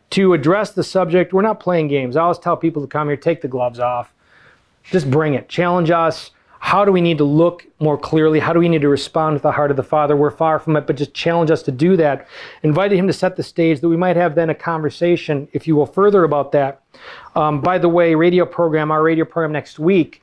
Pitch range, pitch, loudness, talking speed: 145-175 Hz, 160 Hz, -16 LUFS, 250 wpm